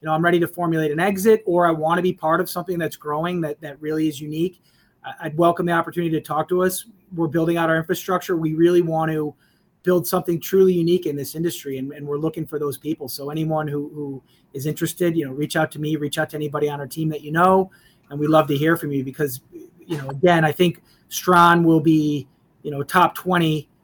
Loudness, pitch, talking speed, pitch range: -21 LUFS, 160 Hz, 240 wpm, 150-175 Hz